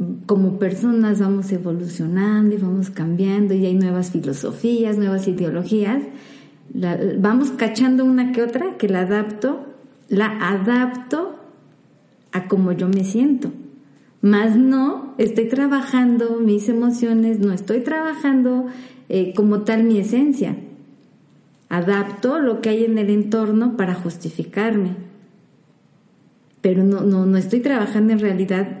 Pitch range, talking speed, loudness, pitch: 195-250 Hz, 125 wpm, -19 LUFS, 215 Hz